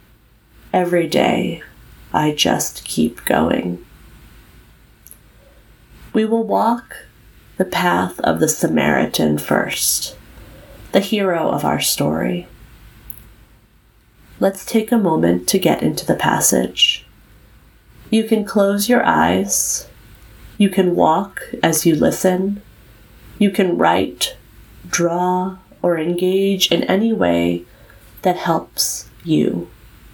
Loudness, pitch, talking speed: -17 LUFS, 170 Hz, 105 wpm